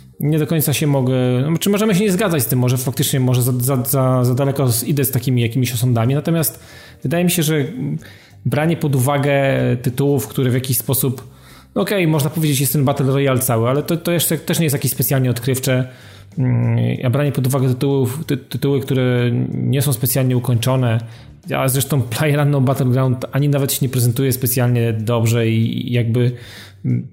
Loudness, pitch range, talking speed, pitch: -17 LUFS, 125-145 Hz, 190 wpm, 130 Hz